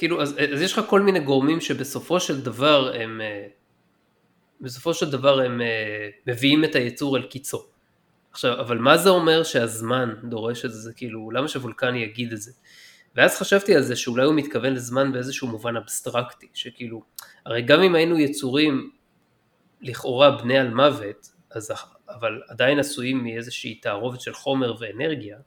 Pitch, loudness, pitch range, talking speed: 130 Hz, -22 LUFS, 120-145 Hz, 155 wpm